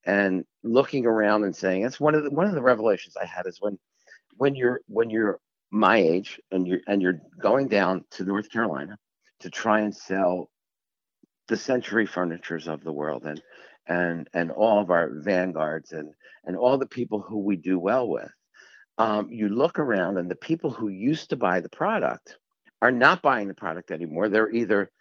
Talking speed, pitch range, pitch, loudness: 190 wpm, 90-115 Hz, 105 Hz, -25 LUFS